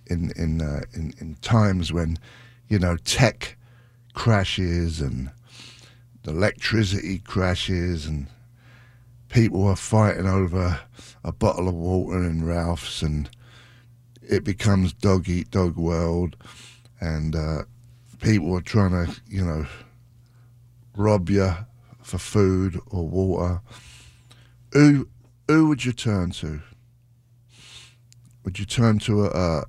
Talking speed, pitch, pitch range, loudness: 120 wpm, 100 Hz, 90-120 Hz, -23 LUFS